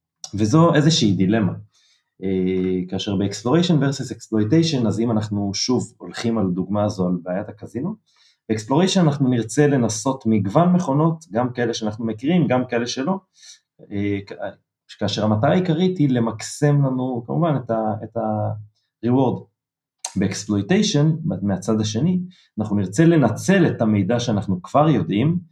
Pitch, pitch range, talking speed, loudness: 115 Hz, 105-150 Hz, 130 wpm, -20 LUFS